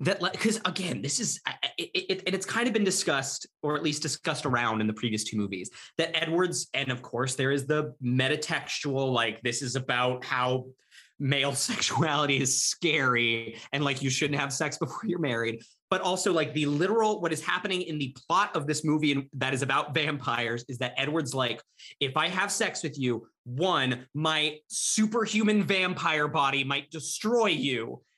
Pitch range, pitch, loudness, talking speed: 130-175 Hz, 150 Hz, -28 LUFS, 185 wpm